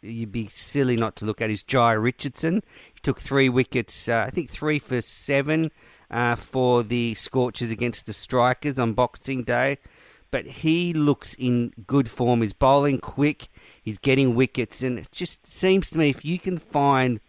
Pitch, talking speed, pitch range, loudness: 125 Hz, 180 wpm, 115-140 Hz, -24 LUFS